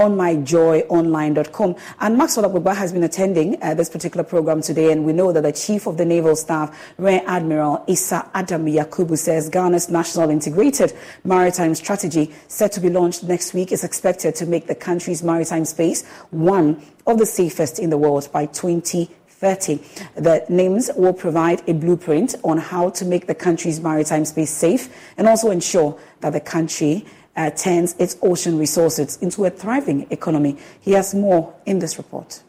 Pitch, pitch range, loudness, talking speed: 170 Hz, 160-185 Hz, -19 LUFS, 170 wpm